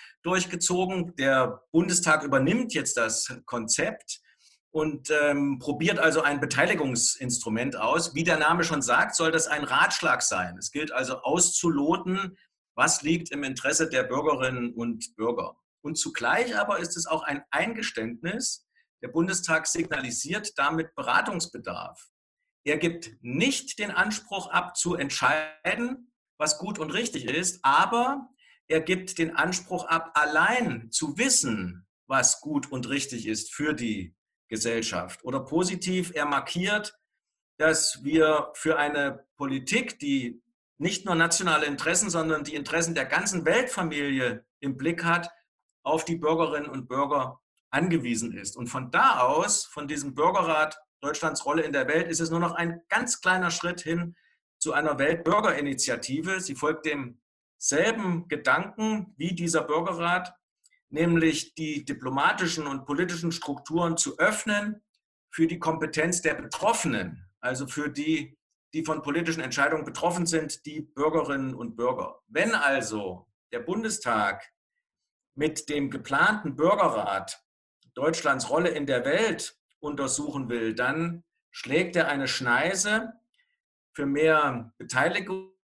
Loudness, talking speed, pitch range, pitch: -26 LUFS, 135 wpm, 140-180 Hz, 160 Hz